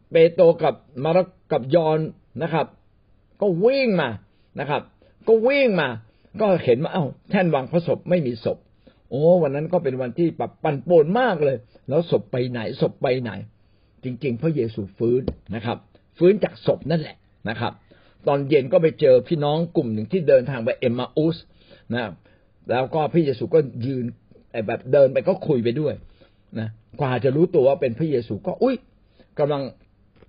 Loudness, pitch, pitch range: -22 LUFS, 135 Hz, 110-170 Hz